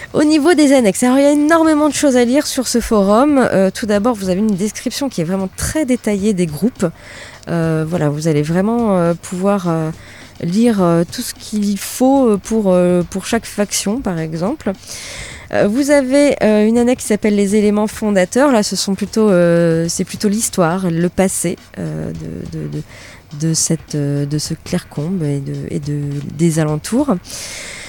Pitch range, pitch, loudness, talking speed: 170-235 Hz, 195 Hz, -15 LUFS, 185 wpm